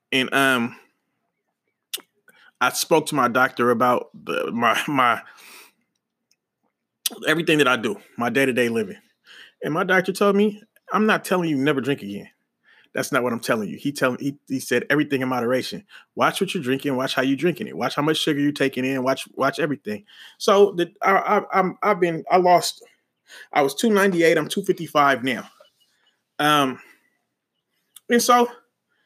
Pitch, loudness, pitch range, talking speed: 150 Hz, -21 LUFS, 130-190 Hz, 180 wpm